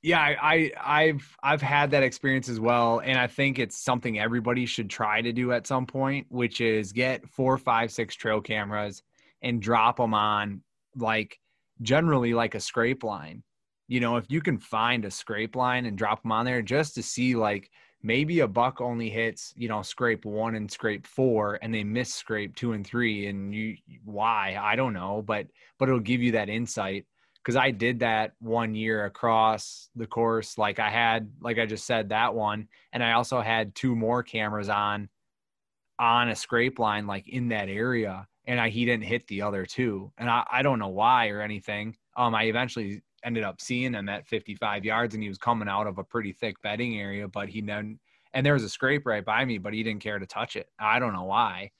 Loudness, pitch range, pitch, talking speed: -27 LUFS, 105-125 Hz, 115 Hz, 215 wpm